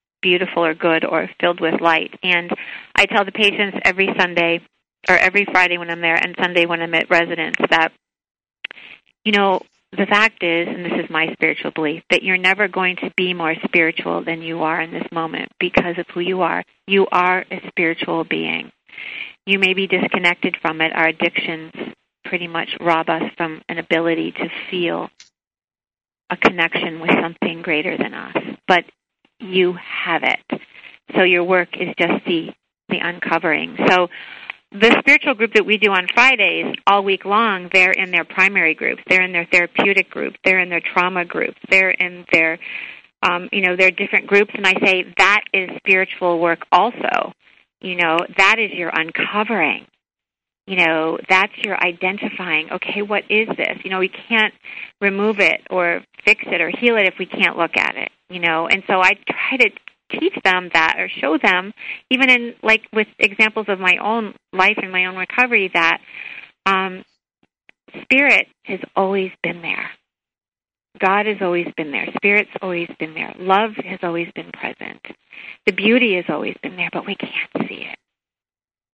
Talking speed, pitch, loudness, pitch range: 175 wpm, 185 Hz, -17 LUFS, 170-200 Hz